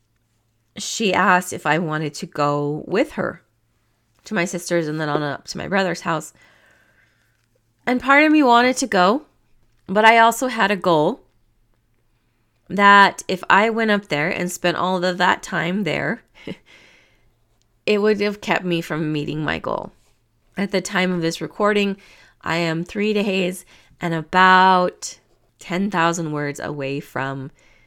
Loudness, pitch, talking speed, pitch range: -19 LUFS, 170 Hz, 155 wpm, 125-195 Hz